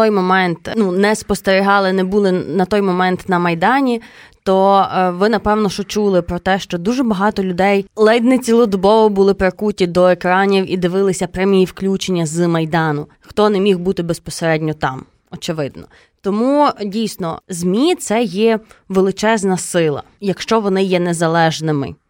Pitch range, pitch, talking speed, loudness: 180-210 Hz, 190 Hz, 145 wpm, -15 LUFS